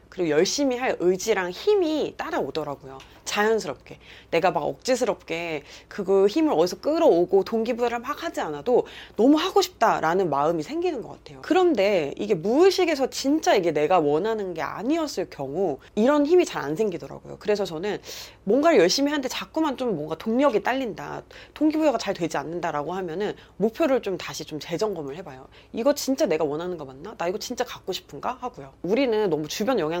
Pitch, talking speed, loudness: 210 Hz, 400 characters per minute, -24 LUFS